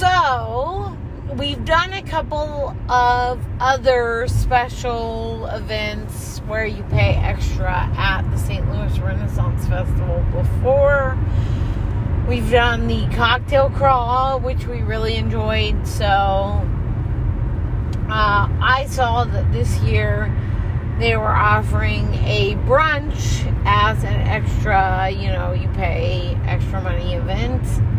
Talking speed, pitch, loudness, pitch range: 110 wpm, 105 Hz, -19 LUFS, 100-110 Hz